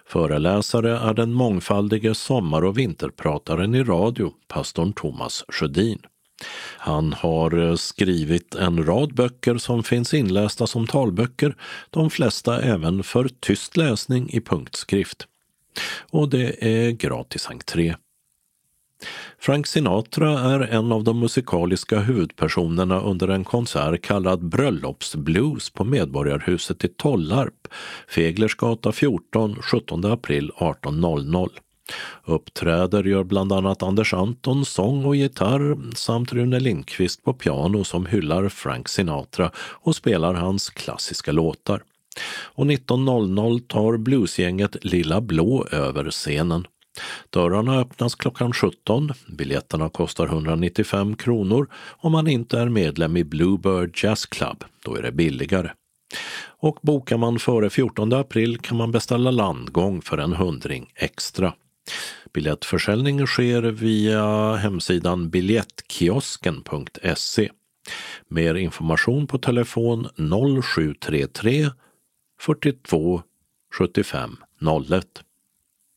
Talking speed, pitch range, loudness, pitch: 110 wpm, 90-125 Hz, -22 LUFS, 110 Hz